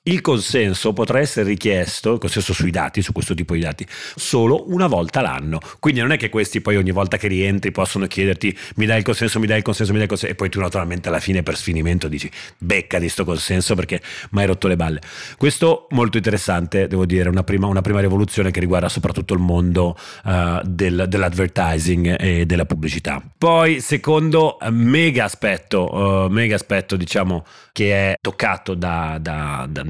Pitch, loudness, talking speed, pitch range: 95 Hz, -19 LUFS, 195 wpm, 90-110 Hz